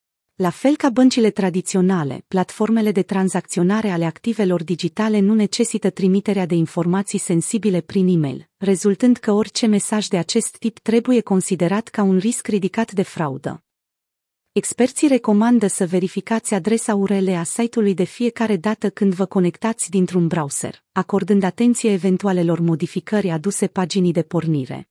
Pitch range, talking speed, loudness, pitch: 180-220 Hz, 140 wpm, -19 LUFS, 195 Hz